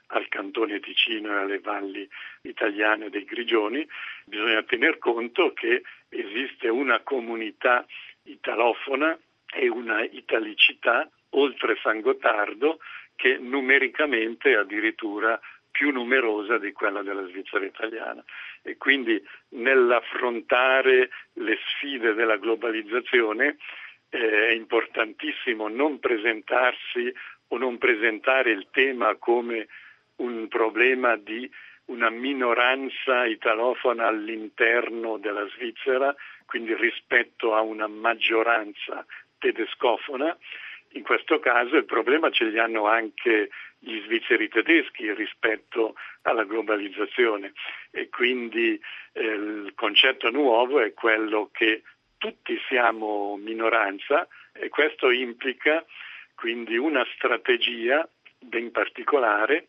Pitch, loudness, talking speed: 130 Hz, -24 LUFS, 105 wpm